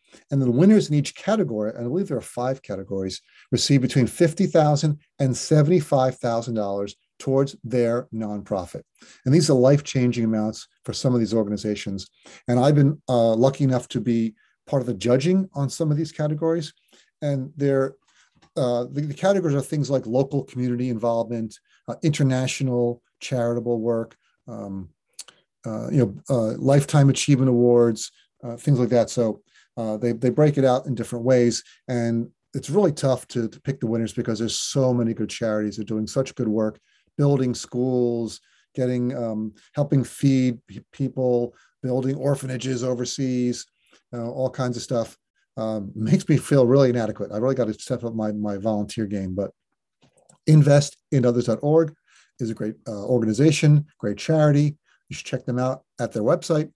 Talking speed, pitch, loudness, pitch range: 165 wpm, 125 Hz, -22 LUFS, 115-140 Hz